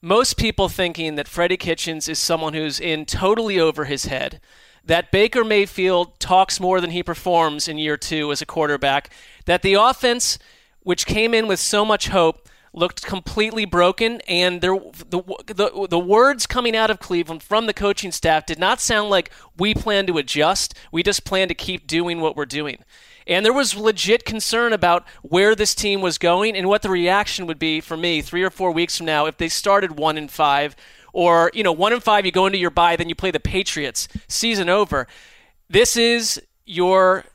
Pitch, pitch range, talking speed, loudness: 185 Hz, 165-205 Hz, 200 wpm, -19 LUFS